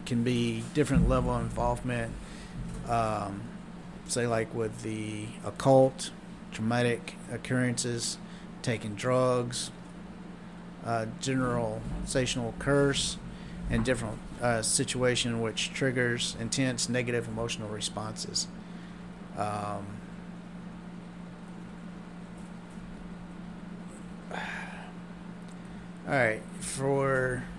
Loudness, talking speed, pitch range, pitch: -30 LUFS, 75 wpm, 120-185 Hz, 150 Hz